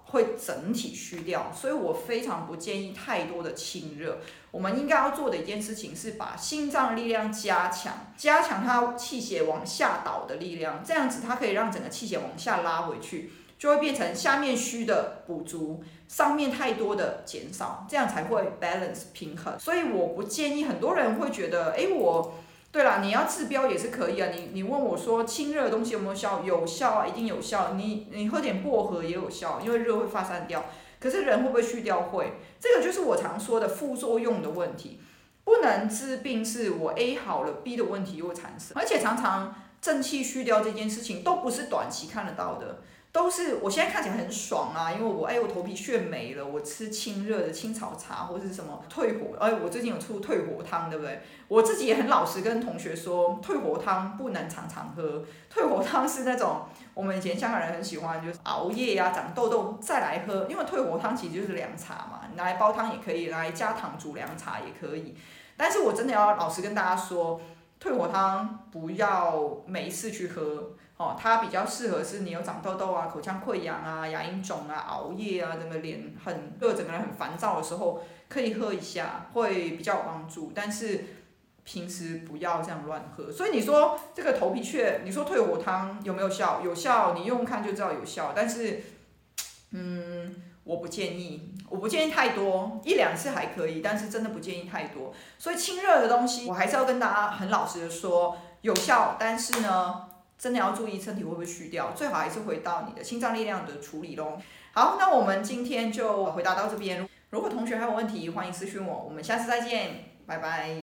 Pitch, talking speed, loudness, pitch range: 205 Hz, 305 characters per minute, -29 LUFS, 175-235 Hz